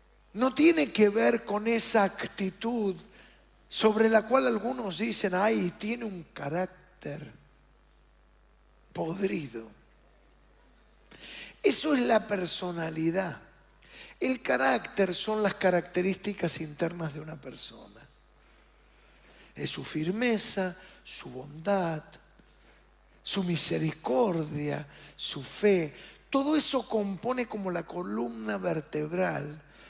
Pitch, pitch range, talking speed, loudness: 190 Hz, 165-220 Hz, 90 wpm, -28 LUFS